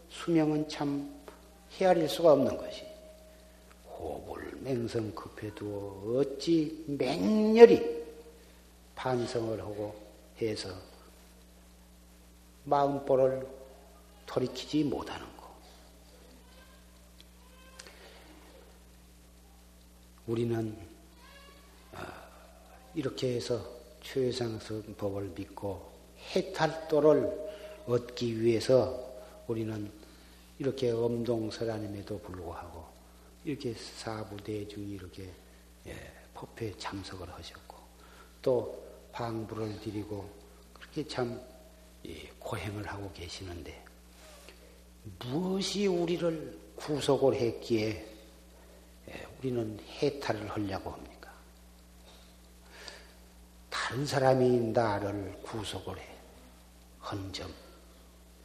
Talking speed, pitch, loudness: 170 characters per minute, 100 Hz, -32 LUFS